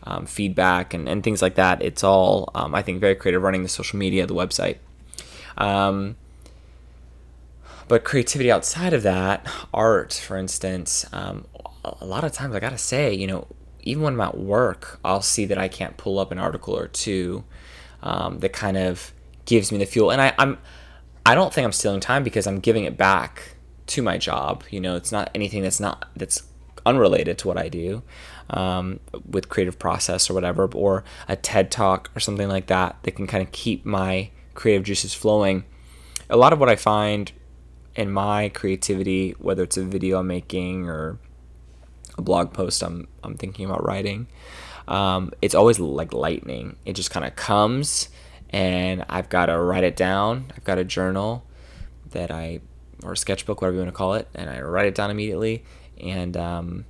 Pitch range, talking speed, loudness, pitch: 80-100 Hz, 190 wpm, -22 LUFS, 95 Hz